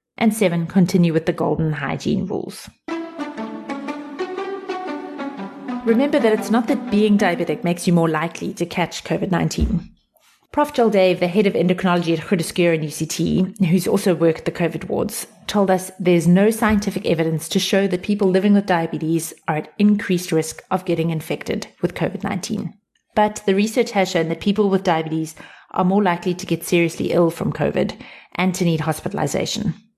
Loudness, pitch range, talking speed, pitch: -20 LUFS, 165-210 Hz, 165 wpm, 185 Hz